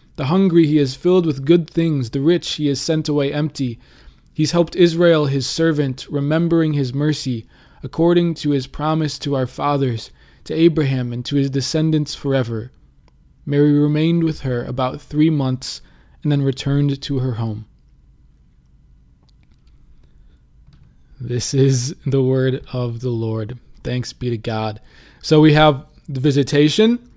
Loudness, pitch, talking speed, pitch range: -18 LUFS, 140 Hz, 145 wpm, 125-155 Hz